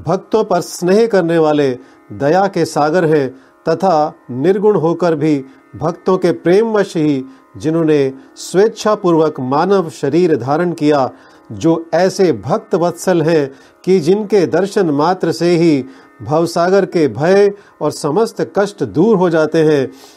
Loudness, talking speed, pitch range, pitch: -14 LUFS, 130 wpm, 150-190 Hz, 165 Hz